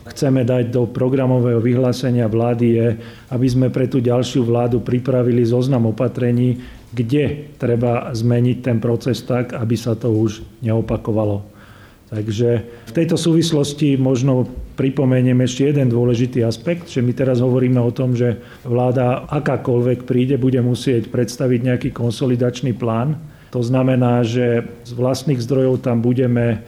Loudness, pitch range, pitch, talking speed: -18 LUFS, 120-130 Hz, 125 Hz, 135 wpm